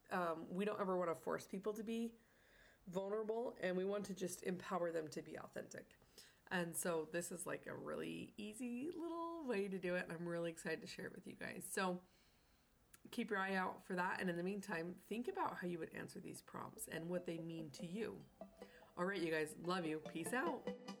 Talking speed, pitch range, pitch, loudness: 220 wpm, 170-215 Hz, 185 Hz, -45 LUFS